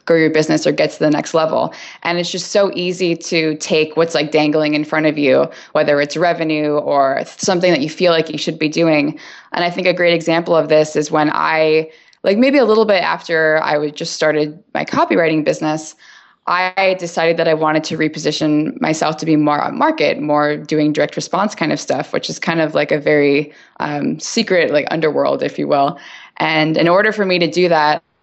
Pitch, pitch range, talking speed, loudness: 160 Hz, 155-175 Hz, 215 wpm, -15 LUFS